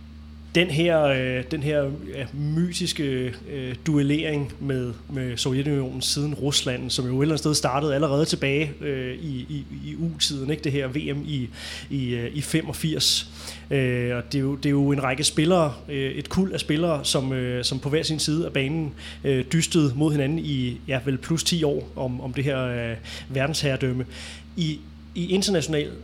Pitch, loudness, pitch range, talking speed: 140 Hz, -25 LUFS, 130-155 Hz, 185 wpm